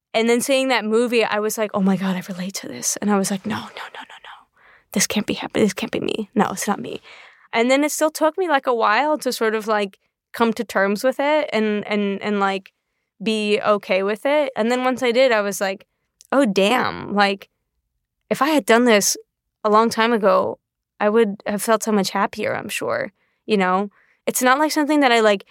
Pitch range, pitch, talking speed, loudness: 205-255 Hz, 220 Hz, 235 wpm, -20 LUFS